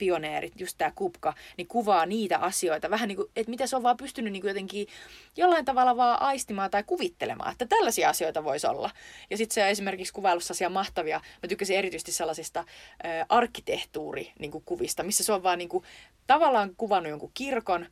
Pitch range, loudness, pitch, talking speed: 180-255 Hz, -28 LUFS, 200 Hz, 175 wpm